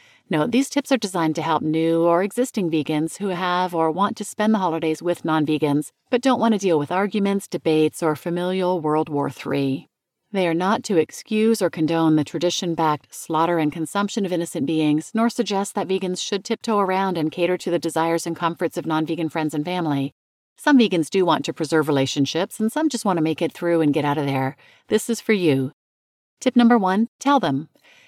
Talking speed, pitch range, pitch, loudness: 215 wpm, 155-205 Hz, 170 Hz, -21 LUFS